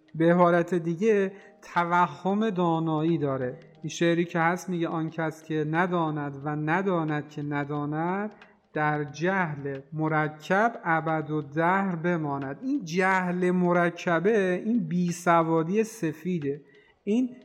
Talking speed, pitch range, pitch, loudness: 115 wpm, 155-180 Hz, 170 Hz, -26 LUFS